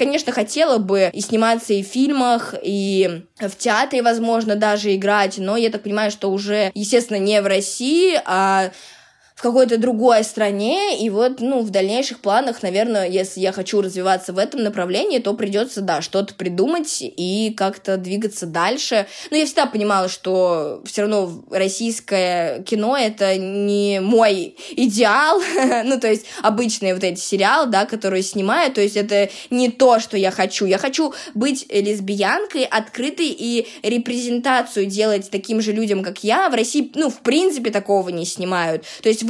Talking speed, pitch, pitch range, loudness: 160 wpm, 210 Hz, 195-240 Hz, -19 LUFS